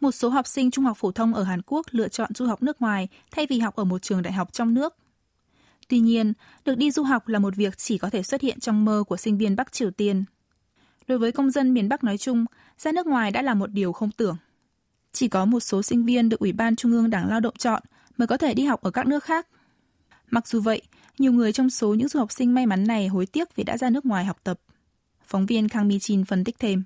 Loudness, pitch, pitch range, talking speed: -24 LUFS, 230 Hz, 205-255 Hz, 270 wpm